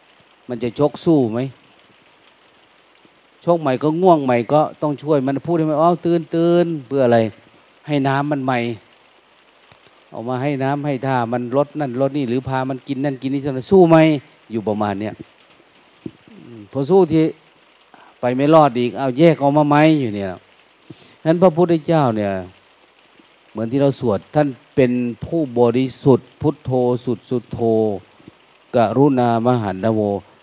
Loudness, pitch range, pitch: -18 LUFS, 120-150 Hz, 135 Hz